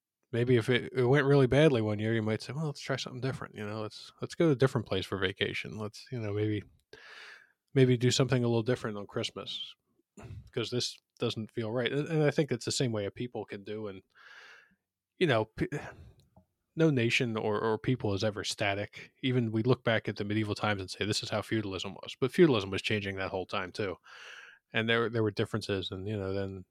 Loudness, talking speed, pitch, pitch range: -31 LUFS, 220 wpm, 110 Hz, 105-125 Hz